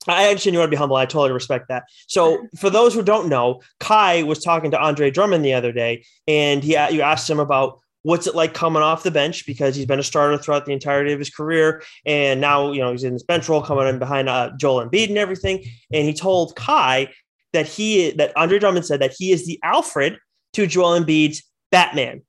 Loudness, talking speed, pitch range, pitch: -18 LUFS, 230 wpm, 135-170 Hz, 150 Hz